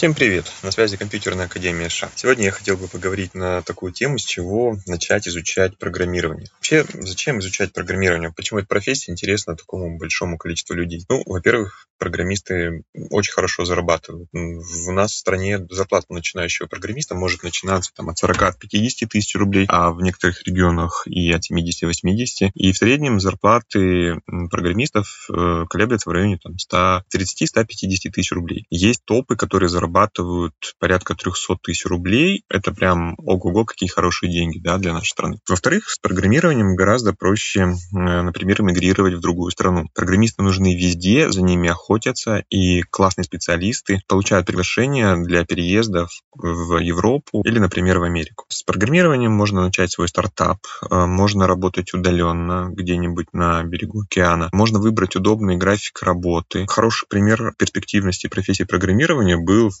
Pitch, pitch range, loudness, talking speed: 95 Hz, 85-100 Hz, -19 LUFS, 145 wpm